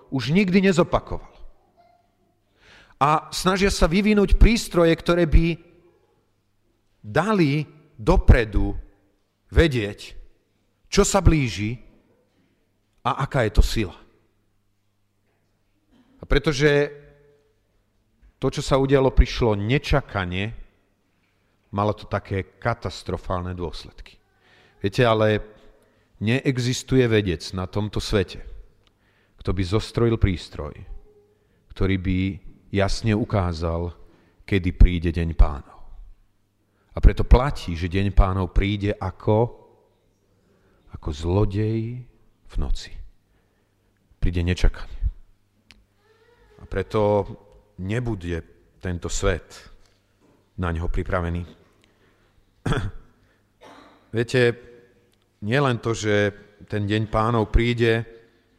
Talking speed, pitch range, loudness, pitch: 85 wpm, 95-120 Hz, -23 LUFS, 105 Hz